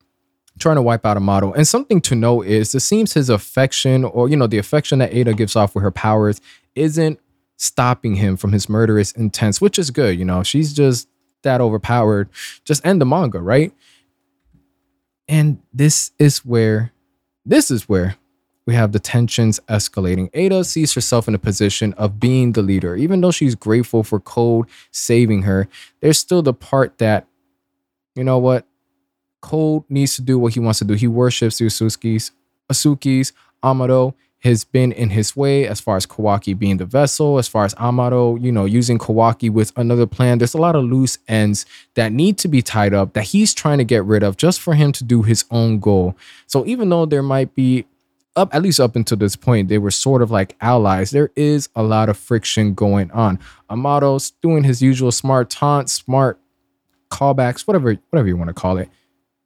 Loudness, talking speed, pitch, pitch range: -16 LUFS, 195 wpm, 115 Hz, 100-135 Hz